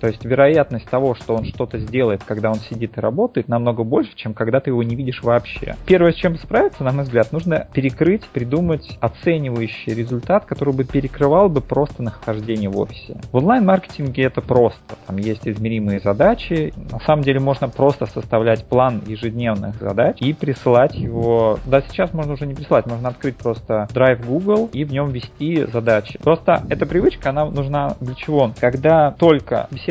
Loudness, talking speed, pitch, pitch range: -18 LUFS, 175 wpm, 130 Hz, 115-145 Hz